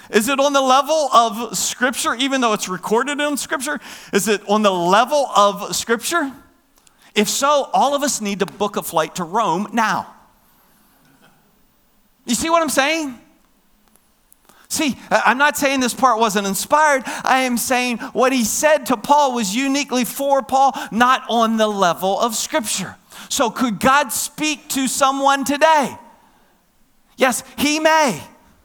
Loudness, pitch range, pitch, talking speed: -17 LUFS, 215-285 Hz, 255 Hz, 155 wpm